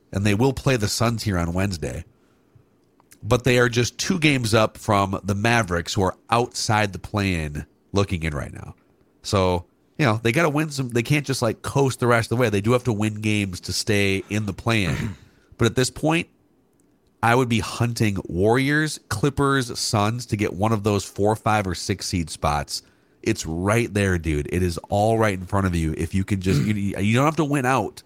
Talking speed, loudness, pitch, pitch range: 215 wpm, -22 LUFS, 105 Hz, 95-120 Hz